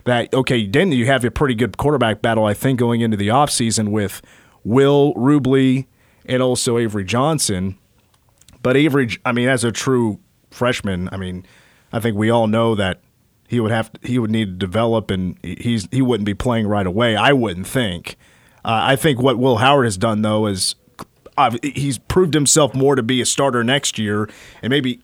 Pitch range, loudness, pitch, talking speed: 110-135 Hz, -17 LUFS, 120 Hz, 195 wpm